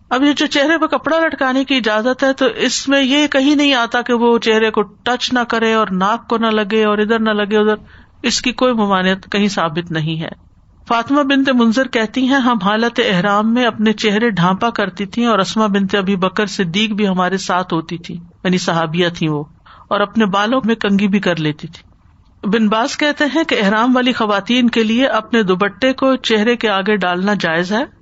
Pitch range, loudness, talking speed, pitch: 195-250 Hz, -15 LUFS, 210 wpm, 220 Hz